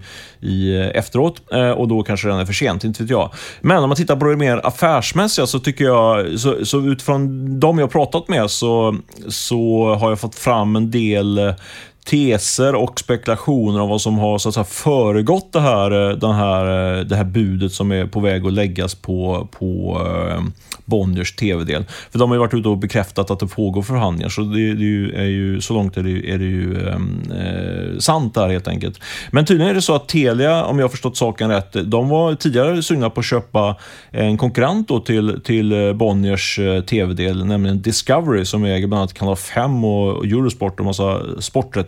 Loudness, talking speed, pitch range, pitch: -17 LUFS, 200 wpm, 100-125 Hz, 110 Hz